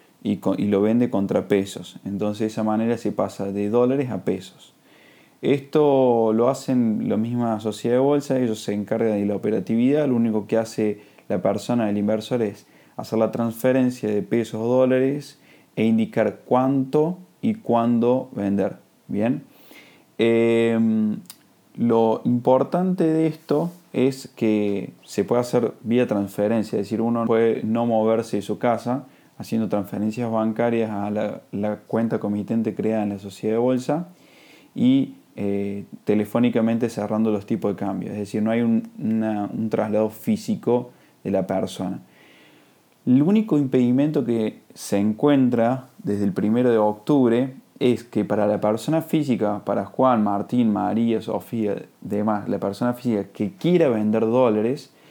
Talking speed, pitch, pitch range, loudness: 150 wpm, 115 Hz, 105-125 Hz, -22 LUFS